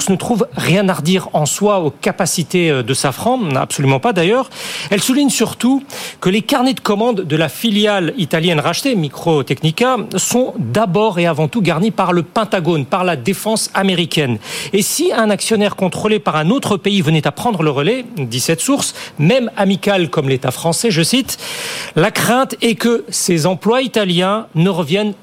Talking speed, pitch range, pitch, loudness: 175 wpm, 165-225 Hz, 195 Hz, -15 LUFS